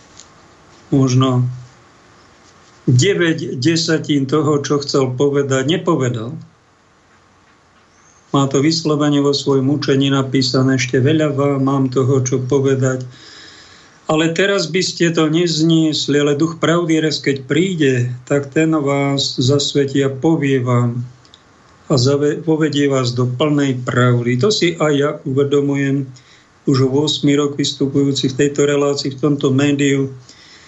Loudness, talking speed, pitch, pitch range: -16 LUFS, 120 wpm, 140 Hz, 135-155 Hz